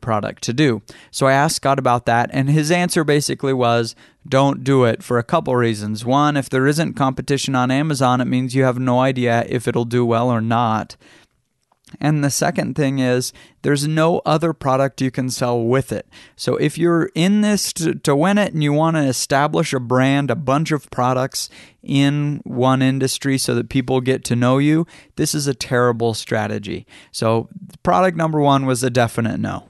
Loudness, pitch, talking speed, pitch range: -18 LUFS, 130 Hz, 195 wpm, 120-145 Hz